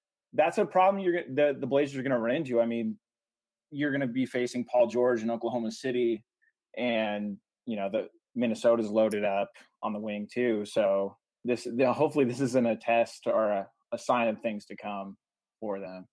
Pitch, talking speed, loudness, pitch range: 115 Hz, 200 wpm, -29 LUFS, 110-135 Hz